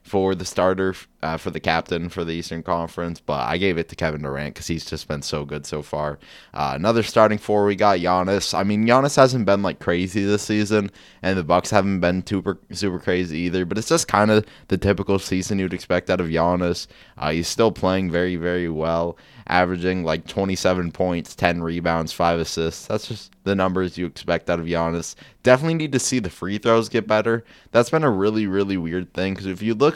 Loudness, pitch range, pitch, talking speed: -22 LUFS, 85-105 Hz, 95 Hz, 220 wpm